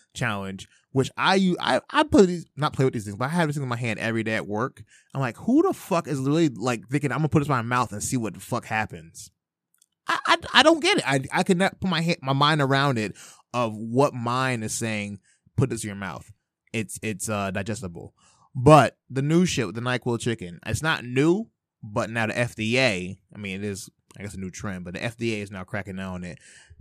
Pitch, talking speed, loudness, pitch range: 120 Hz, 245 wpm, -24 LUFS, 105-145 Hz